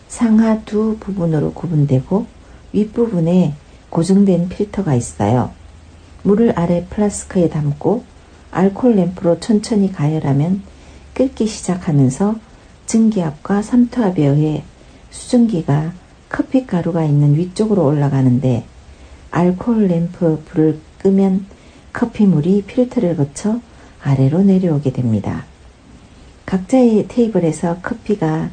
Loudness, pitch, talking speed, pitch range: -16 LUFS, 175 Hz, 260 characters per minute, 145-210 Hz